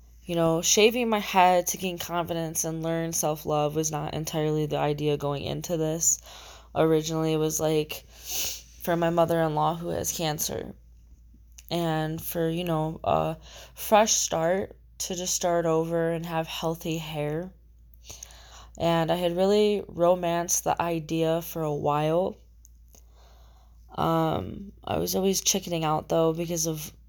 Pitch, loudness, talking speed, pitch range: 160 Hz, -26 LUFS, 140 wpm, 150-170 Hz